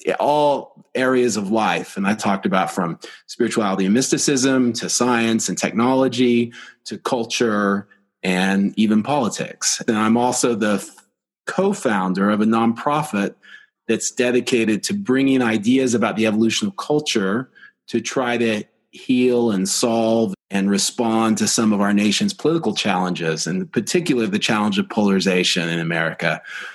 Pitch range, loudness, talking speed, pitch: 100-125 Hz, -19 LUFS, 140 wpm, 115 Hz